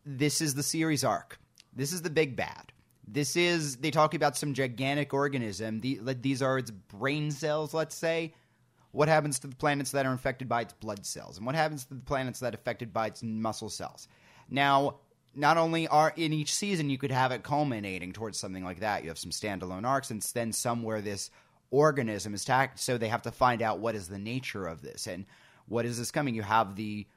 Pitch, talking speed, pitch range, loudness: 130 Hz, 215 wpm, 110-145 Hz, -30 LUFS